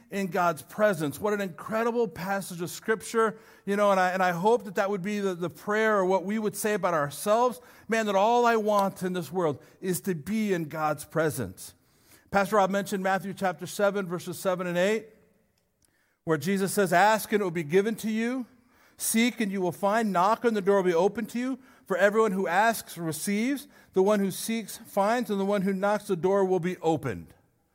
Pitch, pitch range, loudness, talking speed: 200 Hz, 180-220 Hz, -27 LUFS, 215 wpm